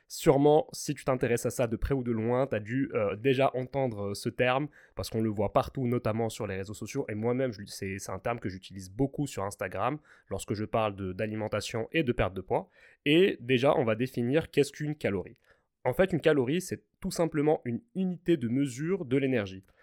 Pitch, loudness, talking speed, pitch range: 125 Hz, -30 LUFS, 215 wpm, 110-145 Hz